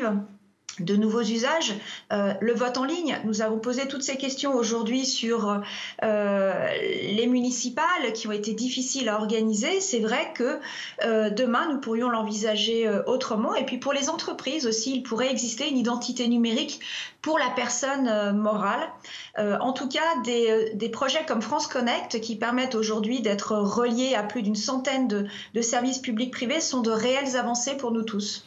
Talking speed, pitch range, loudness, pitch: 175 wpm, 220-265 Hz, -26 LUFS, 240 Hz